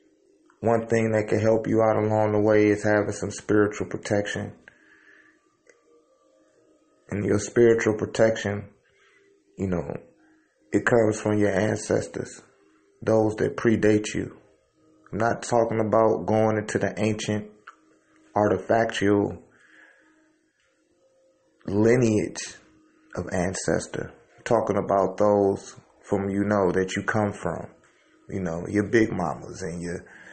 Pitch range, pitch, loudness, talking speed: 100-115 Hz, 105 Hz, -24 LUFS, 120 wpm